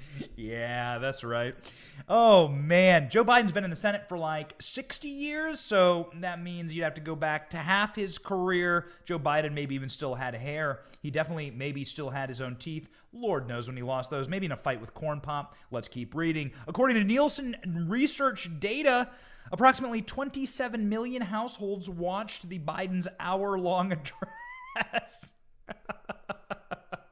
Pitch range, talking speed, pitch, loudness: 145-210 Hz, 160 wpm, 175 Hz, -29 LUFS